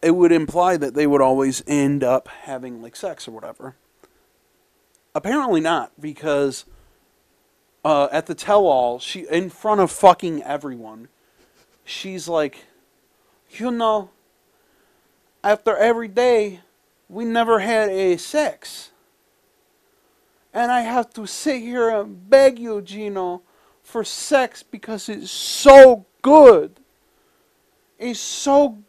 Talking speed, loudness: 120 wpm, -17 LUFS